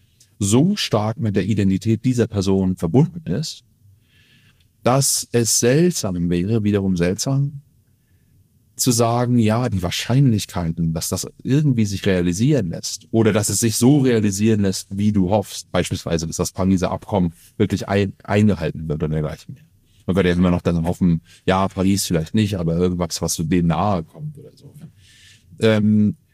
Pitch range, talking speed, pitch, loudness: 90-120 Hz, 160 wpm, 105 Hz, -19 LUFS